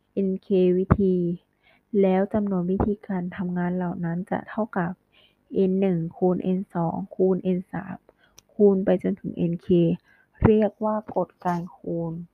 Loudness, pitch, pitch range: -25 LUFS, 185 Hz, 180-195 Hz